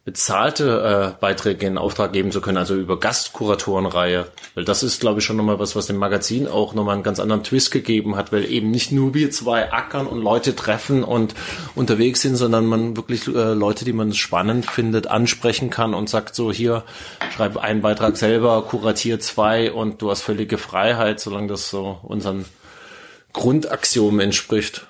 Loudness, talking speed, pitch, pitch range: -20 LUFS, 180 wpm, 110 Hz, 100-115 Hz